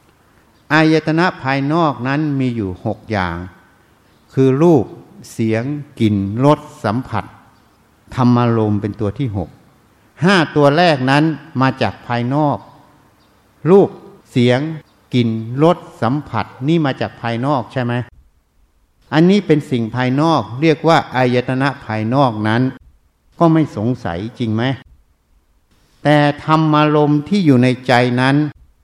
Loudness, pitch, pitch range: -16 LUFS, 125 Hz, 110-150 Hz